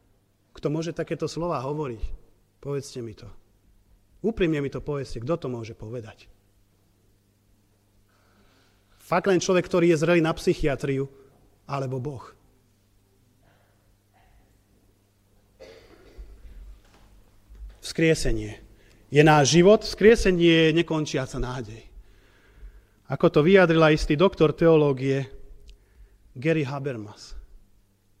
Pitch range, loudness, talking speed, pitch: 100-155 Hz, -23 LUFS, 90 wpm, 120 Hz